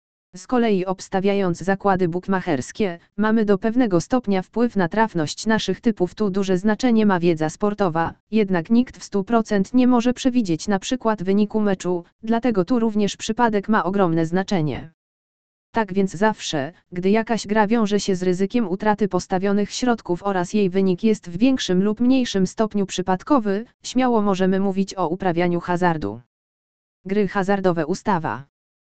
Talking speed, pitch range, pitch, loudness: 145 wpm, 180-220 Hz, 195 Hz, -21 LUFS